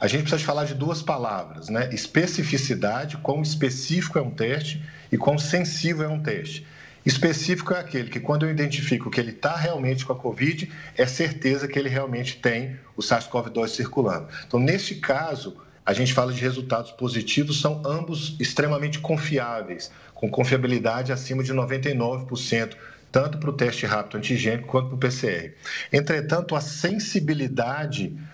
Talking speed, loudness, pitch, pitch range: 160 wpm, -25 LUFS, 140 Hz, 125-155 Hz